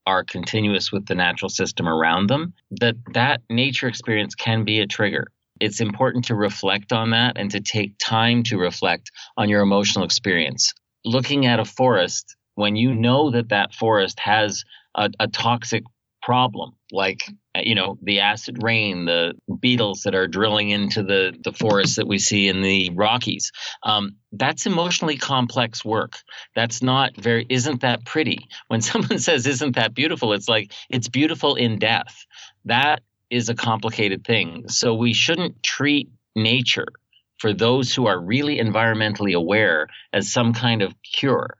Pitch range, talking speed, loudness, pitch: 105-125 Hz, 165 wpm, -20 LUFS, 115 Hz